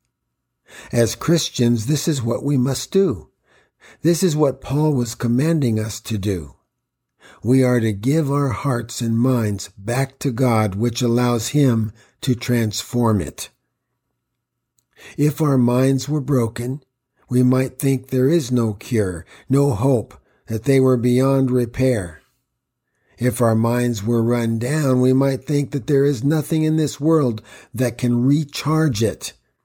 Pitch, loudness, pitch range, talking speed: 125 Hz, -19 LUFS, 115-140 Hz, 150 wpm